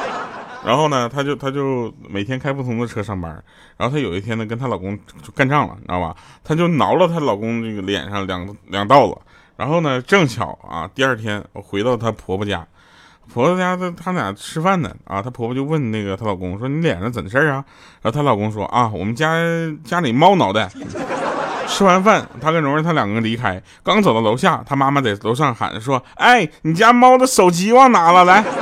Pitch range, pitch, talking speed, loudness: 105-160 Hz, 130 Hz, 305 characters per minute, -17 LUFS